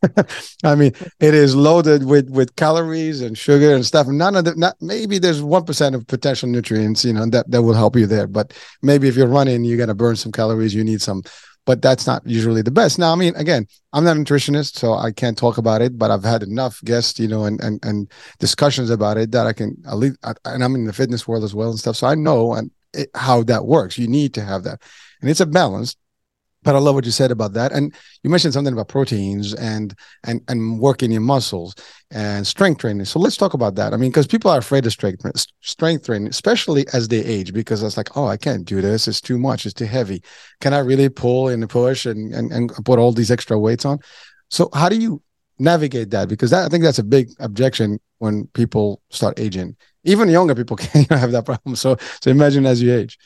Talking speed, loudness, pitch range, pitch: 240 wpm, -17 LUFS, 110-145 Hz, 125 Hz